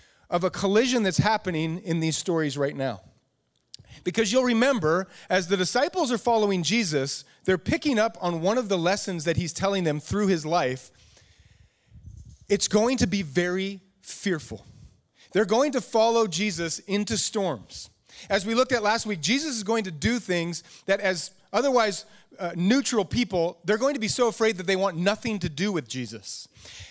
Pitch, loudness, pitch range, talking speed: 190 Hz, -25 LUFS, 160-220 Hz, 175 wpm